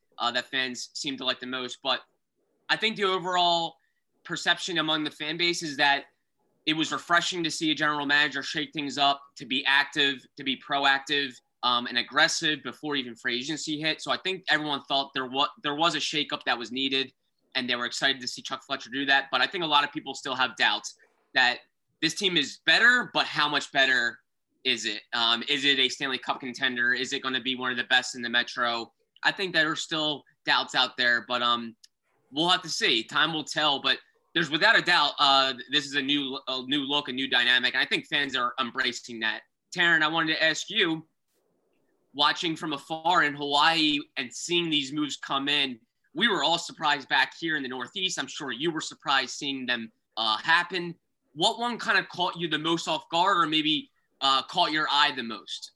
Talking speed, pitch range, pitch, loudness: 215 wpm, 130-160 Hz, 145 Hz, -25 LUFS